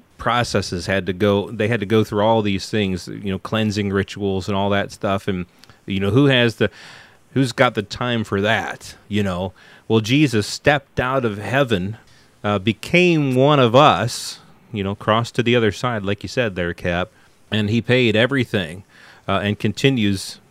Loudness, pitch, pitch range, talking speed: -19 LUFS, 105 Hz, 100-120 Hz, 185 wpm